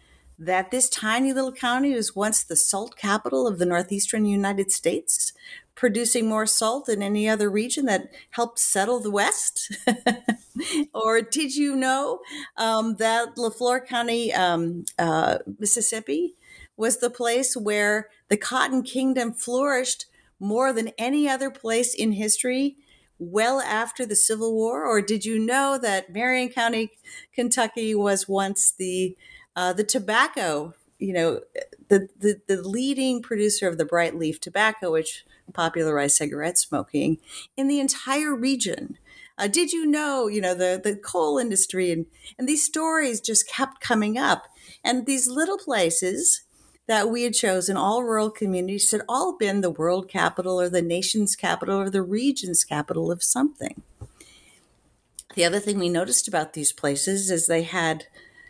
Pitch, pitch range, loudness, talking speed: 220 Hz, 190-255 Hz, -23 LUFS, 150 wpm